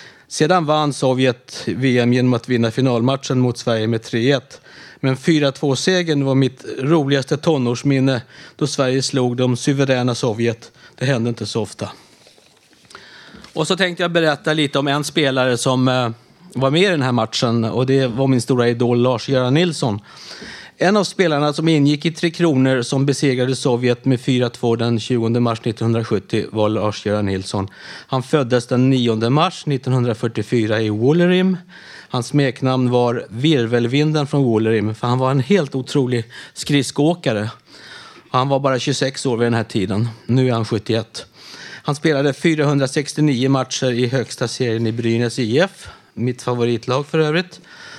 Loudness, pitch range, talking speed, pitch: -18 LUFS, 120-145 Hz, 150 wpm, 130 Hz